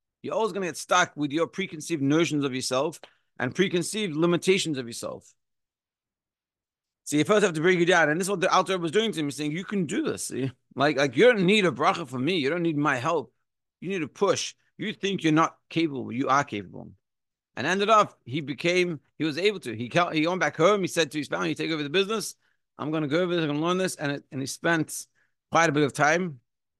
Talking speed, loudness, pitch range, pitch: 255 wpm, -25 LUFS, 135-180 Hz, 160 Hz